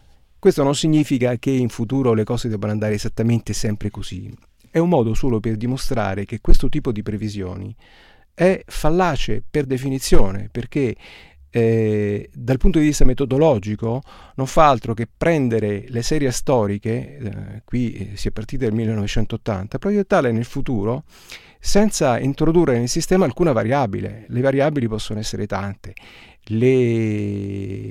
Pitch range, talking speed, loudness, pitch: 105-135 Hz, 140 wpm, -20 LUFS, 115 Hz